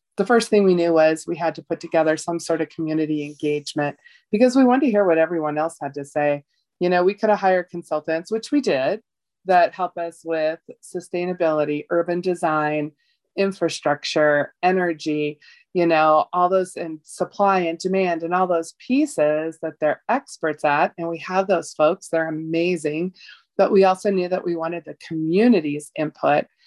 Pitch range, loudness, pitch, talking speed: 155-185 Hz, -21 LUFS, 170 Hz, 180 wpm